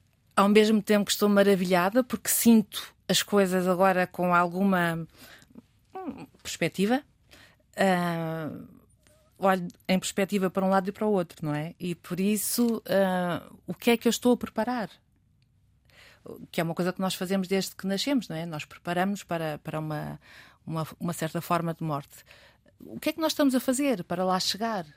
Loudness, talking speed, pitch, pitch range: -27 LUFS, 180 wpm, 185 Hz, 165-205 Hz